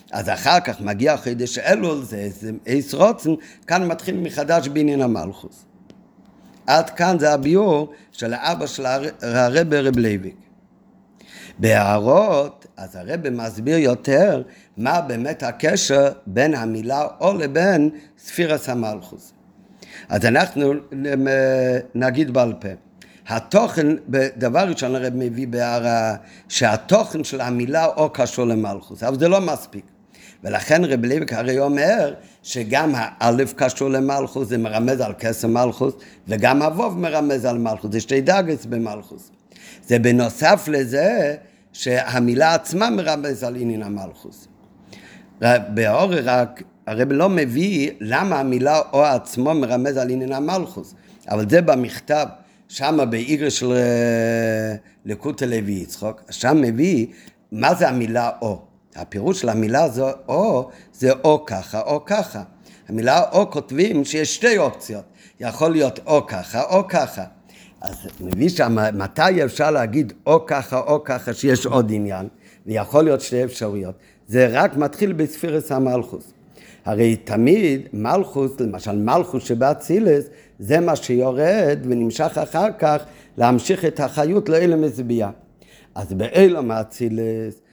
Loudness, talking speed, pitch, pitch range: -19 LUFS, 125 wpm, 130 Hz, 115-155 Hz